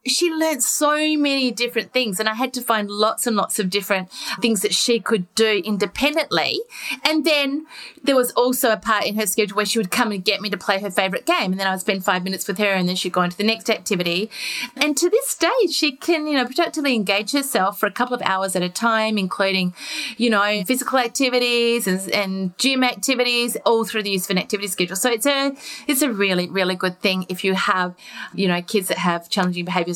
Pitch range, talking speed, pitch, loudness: 195-260 Hz, 230 wpm, 220 Hz, -20 LUFS